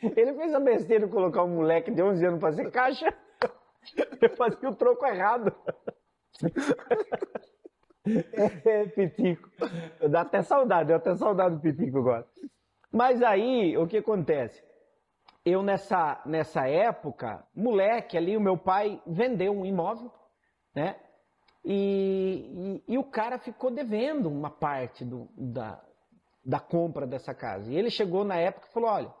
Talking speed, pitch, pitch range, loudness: 150 wpm, 200 Hz, 170-240 Hz, -28 LUFS